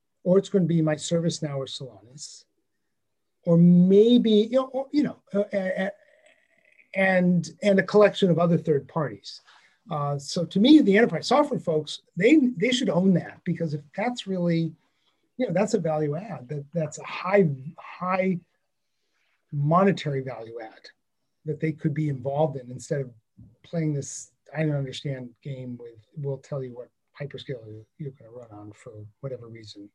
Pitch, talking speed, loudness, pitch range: 160 Hz, 175 wpm, -24 LUFS, 140-190 Hz